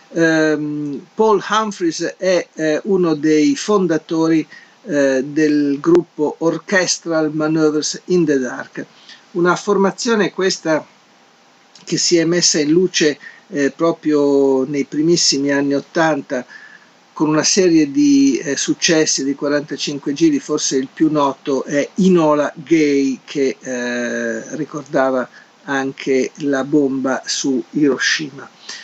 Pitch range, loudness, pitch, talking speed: 140-175 Hz, -16 LUFS, 155 Hz, 115 wpm